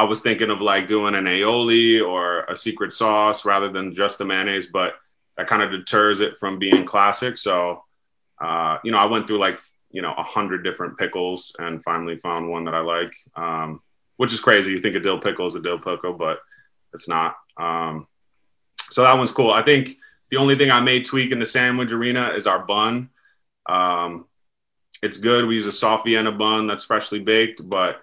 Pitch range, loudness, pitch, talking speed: 90-115 Hz, -20 LUFS, 105 Hz, 205 wpm